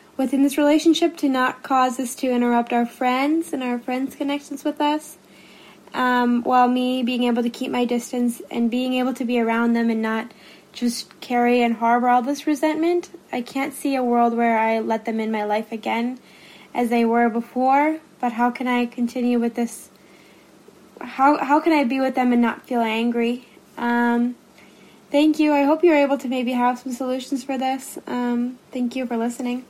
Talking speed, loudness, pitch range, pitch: 195 wpm, -21 LUFS, 235-275 Hz, 250 Hz